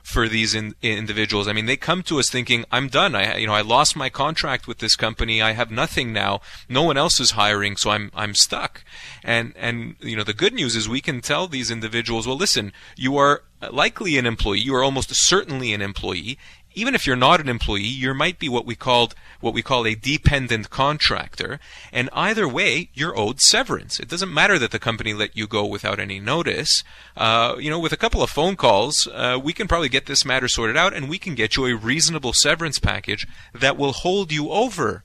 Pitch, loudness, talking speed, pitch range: 120 Hz, -20 LUFS, 225 wpm, 110-145 Hz